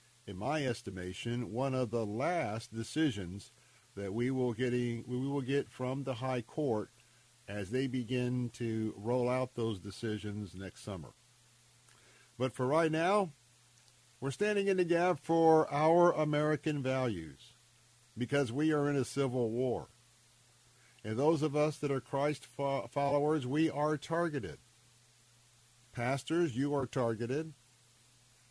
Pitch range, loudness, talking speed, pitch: 120-140 Hz, -34 LUFS, 135 wpm, 125 Hz